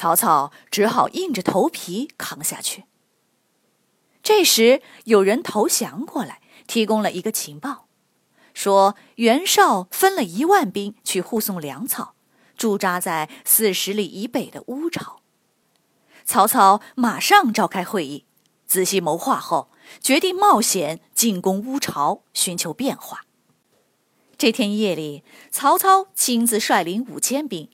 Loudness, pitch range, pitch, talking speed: -19 LUFS, 195-270 Hz, 225 Hz, 190 characters per minute